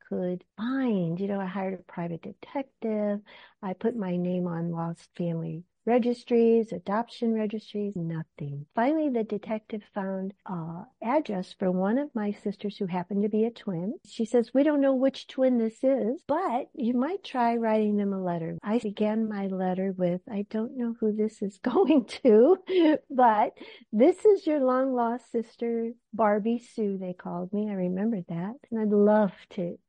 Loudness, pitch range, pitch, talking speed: -28 LUFS, 190-240 Hz, 215 Hz, 175 wpm